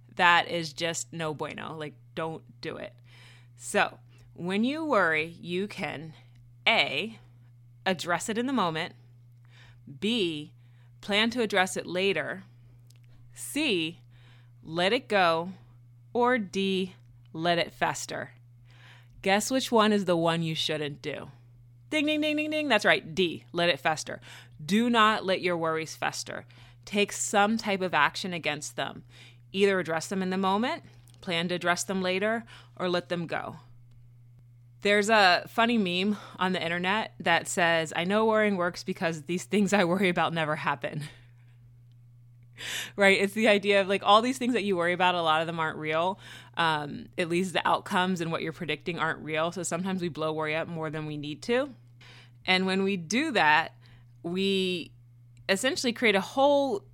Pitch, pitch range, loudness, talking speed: 165 Hz, 120-195 Hz, -27 LUFS, 165 wpm